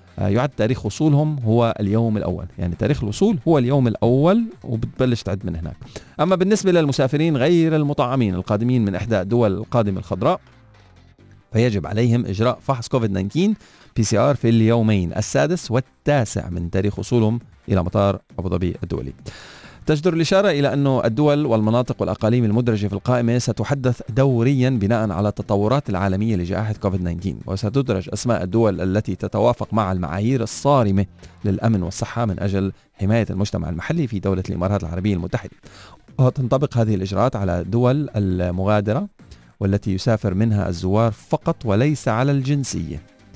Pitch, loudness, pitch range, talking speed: 110 Hz, -20 LUFS, 100-130 Hz, 135 wpm